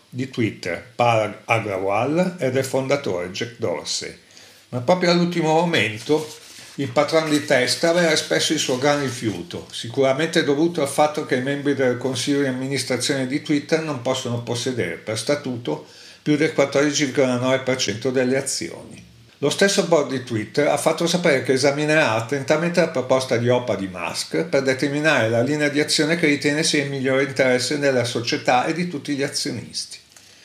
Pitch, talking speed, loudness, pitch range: 140 Hz, 160 wpm, -21 LUFS, 125-150 Hz